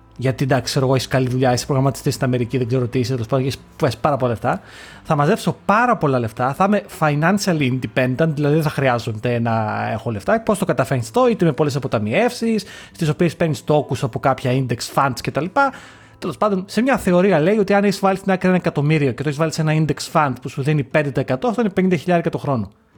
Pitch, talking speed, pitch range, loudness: 145 Hz, 220 wpm, 130-180 Hz, -19 LUFS